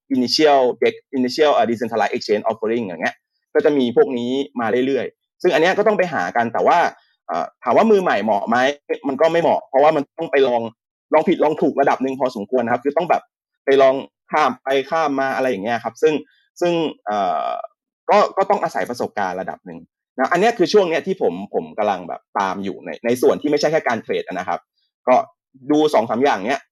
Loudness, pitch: -19 LUFS, 155 Hz